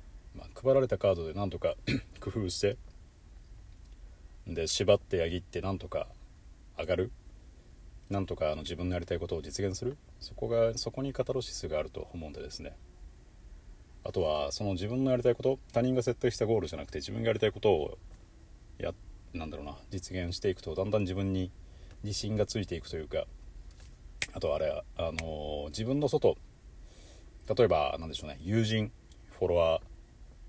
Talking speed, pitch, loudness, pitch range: 335 characters per minute, 90 Hz, -32 LUFS, 80-105 Hz